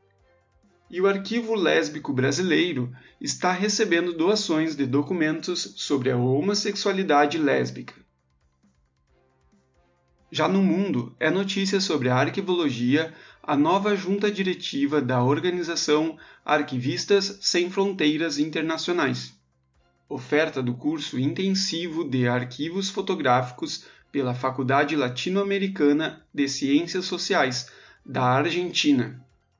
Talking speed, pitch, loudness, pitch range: 95 wpm, 150 Hz, -24 LUFS, 125-185 Hz